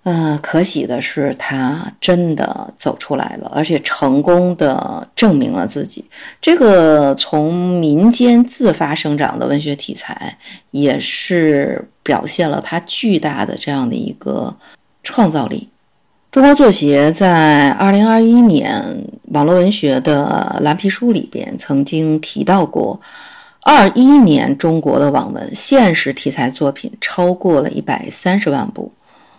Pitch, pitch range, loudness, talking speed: 175 Hz, 150-235 Hz, -13 LUFS, 205 characters per minute